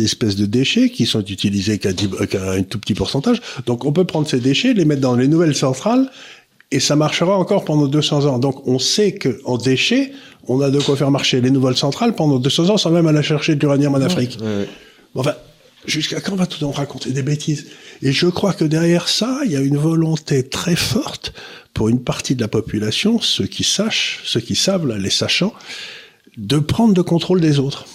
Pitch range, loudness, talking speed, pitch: 130-175 Hz, -17 LUFS, 220 wpm, 145 Hz